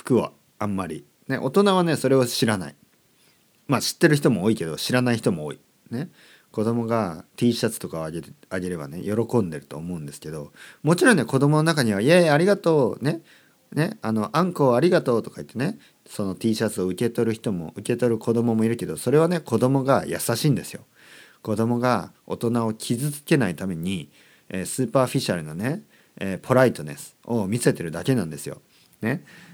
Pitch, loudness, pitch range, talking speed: 115 Hz, -23 LUFS, 105-135 Hz, 345 characters per minute